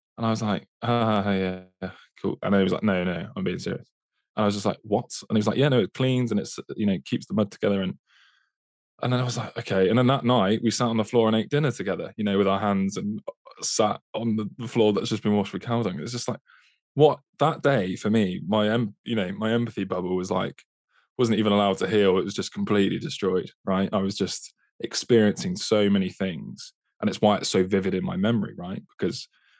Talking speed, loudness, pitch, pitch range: 245 wpm, -25 LUFS, 110 Hz, 100-115 Hz